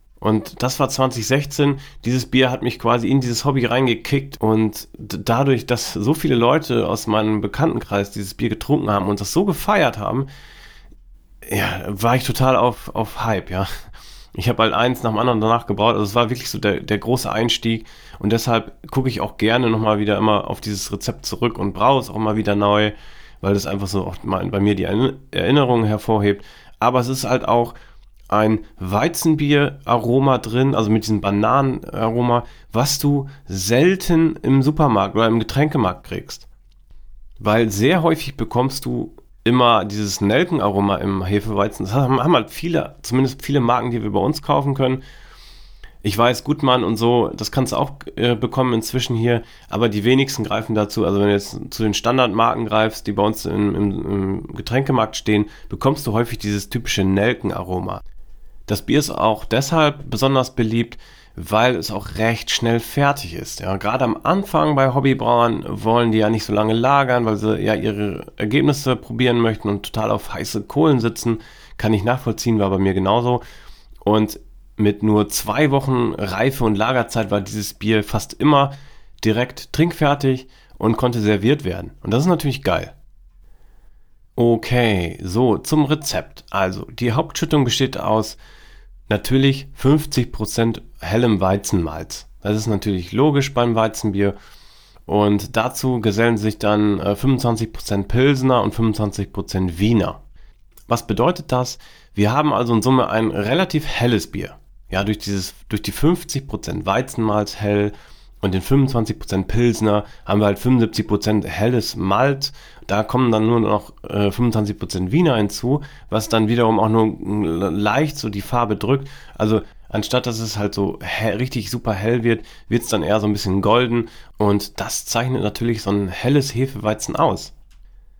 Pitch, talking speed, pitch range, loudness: 115 Hz, 165 wpm, 105-130 Hz, -19 LUFS